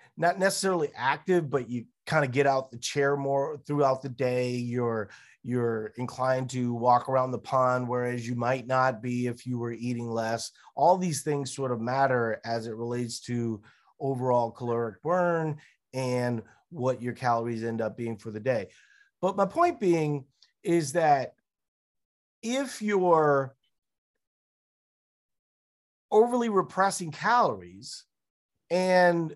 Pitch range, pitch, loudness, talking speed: 120-170 Hz, 130 Hz, -28 LUFS, 140 wpm